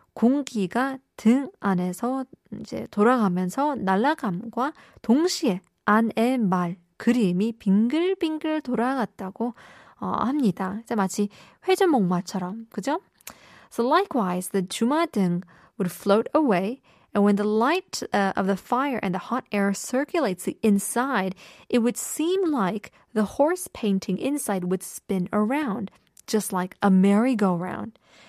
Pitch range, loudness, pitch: 195-260 Hz, -24 LUFS, 215 Hz